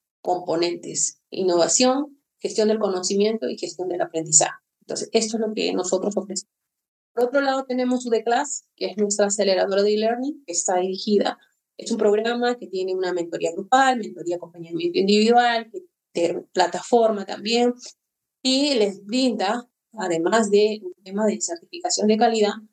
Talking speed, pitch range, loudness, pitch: 145 wpm, 180-235 Hz, -22 LUFS, 210 Hz